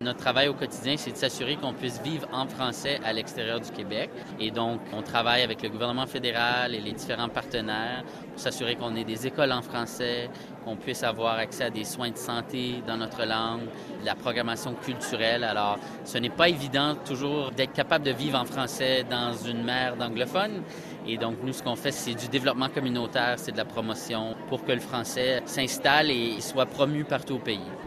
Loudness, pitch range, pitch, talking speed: -28 LUFS, 115-135 Hz, 125 Hz, 200 wpm